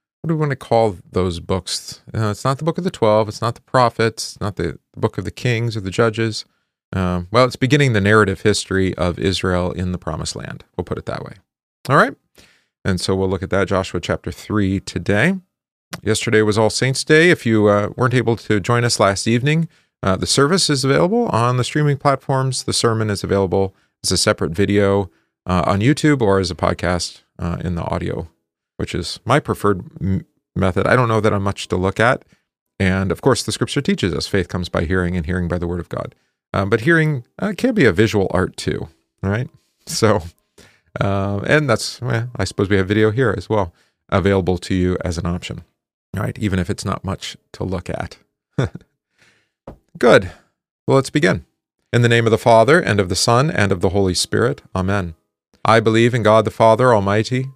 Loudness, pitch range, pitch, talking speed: -18 LUFS, 95-125 Hz, 105 Hz, 210 wpm